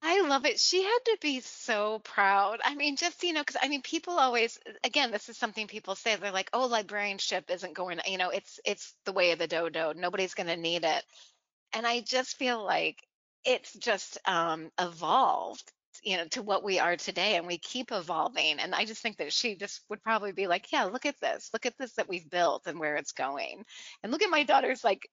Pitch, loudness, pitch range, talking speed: 215 Hz, -30 LUFS, 185-255 Hz, 230 wpm